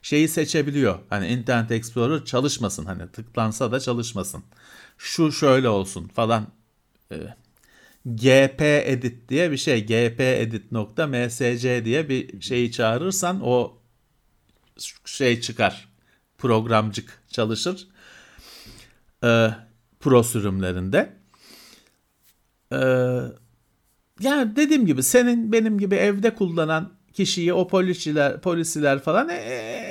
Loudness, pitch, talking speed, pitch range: -22 LUFS, 125 Hz, 100 wpm, 115-160 Hz